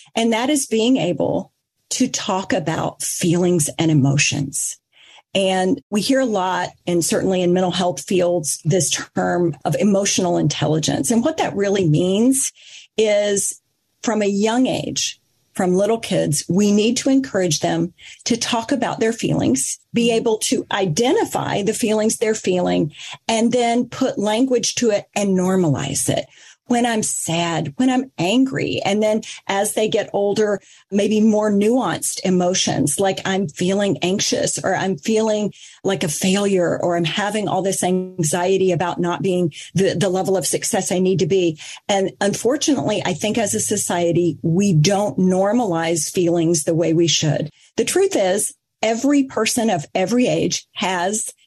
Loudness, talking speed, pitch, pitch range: -19 LUFS, 155 wpm, 195 Hz, 175-220 Hz